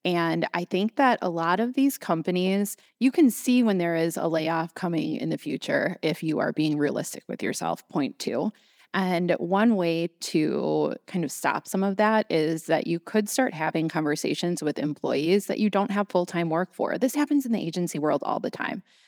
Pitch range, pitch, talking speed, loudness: 165-220 Hz, 180 Hz, 210 wpm, -26 LUFS